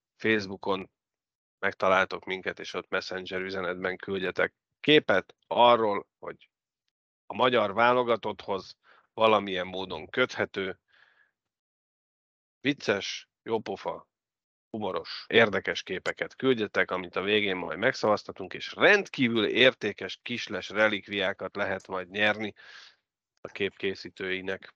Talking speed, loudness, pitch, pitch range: 90 wpm, -28 LUFS, 95 Hz, 95-110 Hz